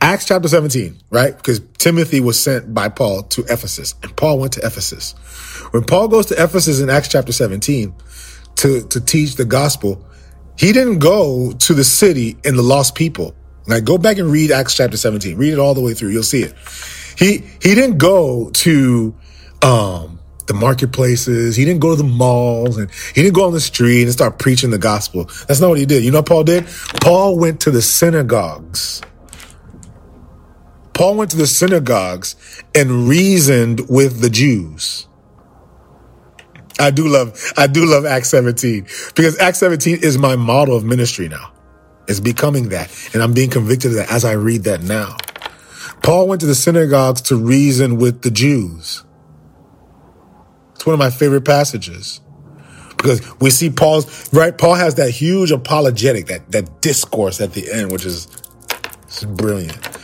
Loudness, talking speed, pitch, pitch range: -14 LUFS, 175 wpm, 125 Hz, 105-150 Hz